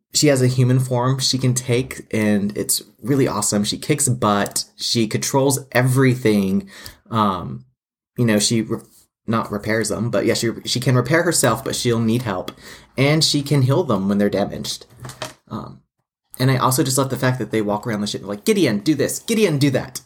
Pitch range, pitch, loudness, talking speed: 105-135 Hz, 120 Hz, -19 LUFS, 200 wpm